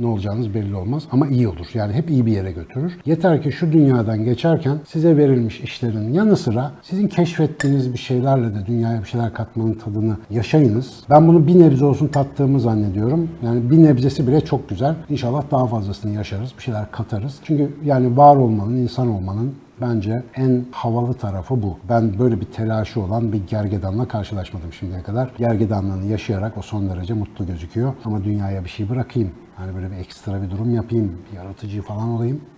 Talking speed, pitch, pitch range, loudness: 180 wpm, 115 Hz, 105-135 Hz, -19 LUFS